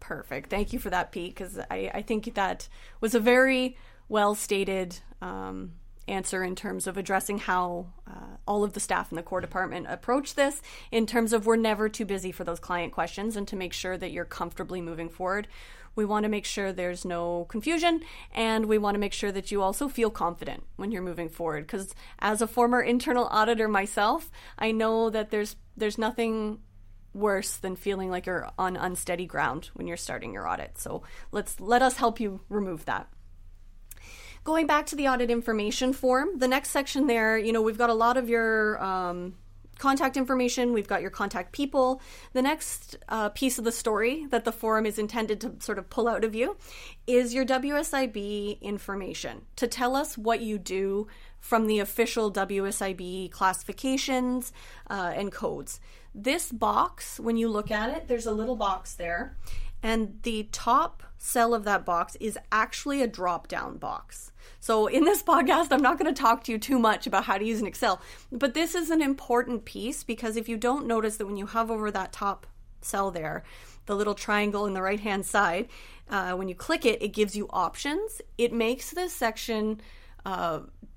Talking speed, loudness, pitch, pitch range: 195 wpm, -28 LUFS, 215 Hz, 190-240 Hz